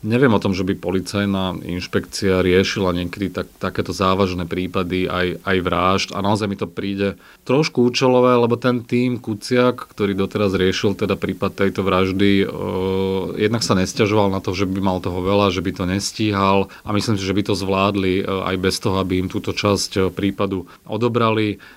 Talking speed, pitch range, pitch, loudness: 185 wpm, 95-105 Hz, 95 Hz, -19 LUFS